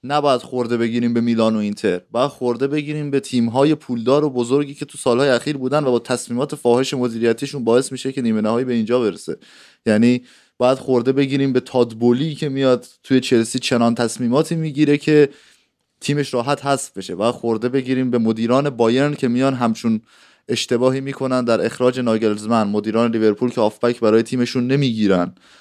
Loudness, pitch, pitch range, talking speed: -19 LUFS, 125 Hz, 115-140 Hz, 170 wpm